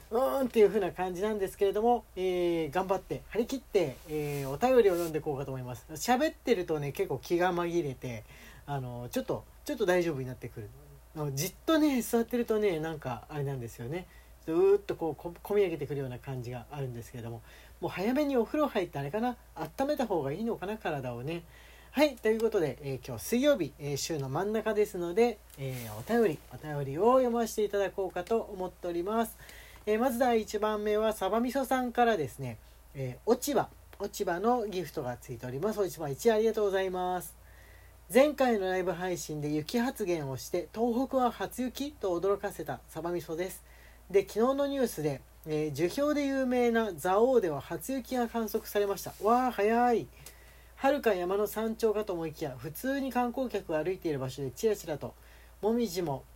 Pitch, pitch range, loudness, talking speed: 190 Hz, 150-230 Hz, -31 LUFS, 390 characters per minute